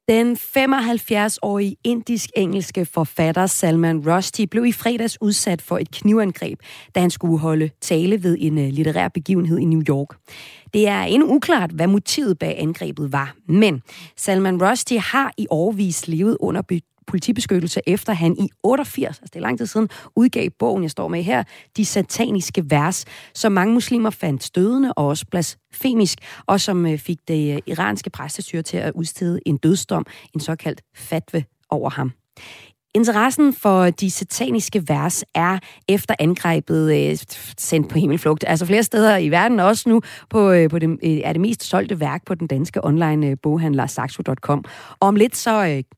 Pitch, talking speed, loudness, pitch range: 180 Hz, 155 wpm, -19 LUFS, 155-210 Hz